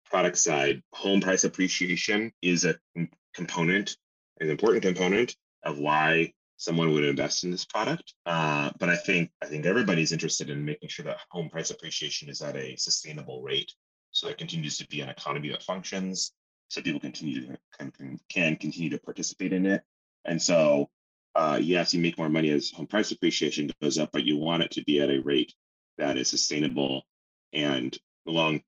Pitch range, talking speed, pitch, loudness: 75-90 Hz, 180 wpm, 80 Hz, -27 LUFS